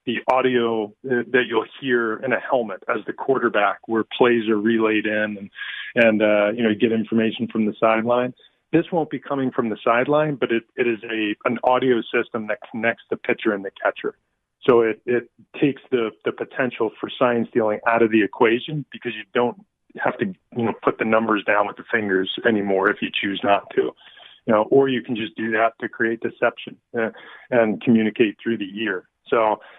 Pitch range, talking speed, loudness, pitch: 110-125 Hz, 200 wpm, -21 LUFS, 115 Hz